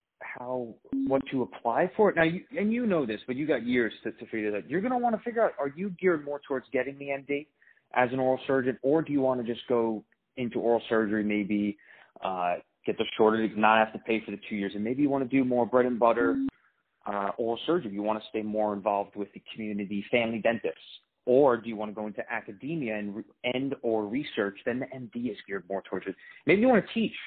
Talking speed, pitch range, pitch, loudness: 245 wpm, 105-135 Hz, 120 Hz, -29 LUFS